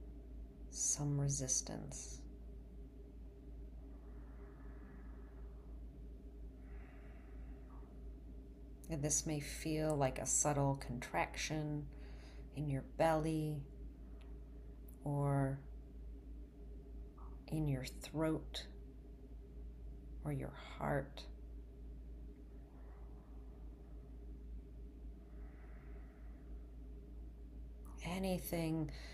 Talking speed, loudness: 45 wpm, -40 LUFS